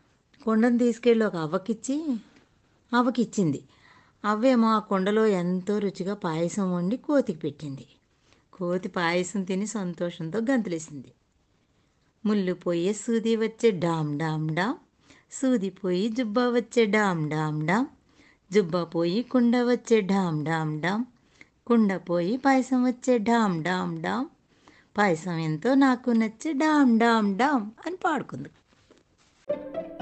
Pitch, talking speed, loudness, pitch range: 210 Hz, 110 wpm, -26 LUFS, 175-245 Hz